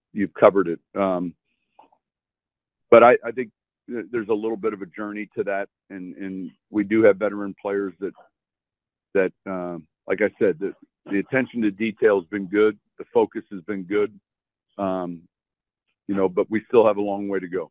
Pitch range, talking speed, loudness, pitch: 95-110 Hz, 185 wpm, -22 LUFS, 100 Hz